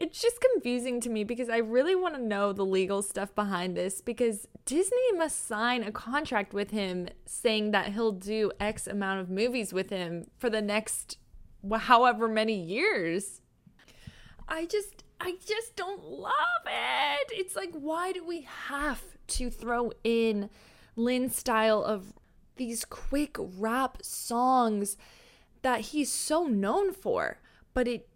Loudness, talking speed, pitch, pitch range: -30 LUFS, 150 wpm, 235 Hz, 210-290 Hz